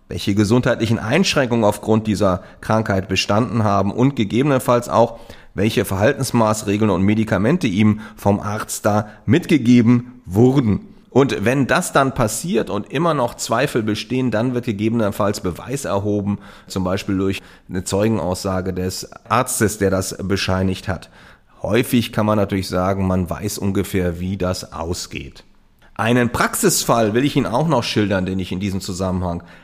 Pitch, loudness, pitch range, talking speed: 105 Hz, -19 LUFS, 95-120 Hz, 145 wpm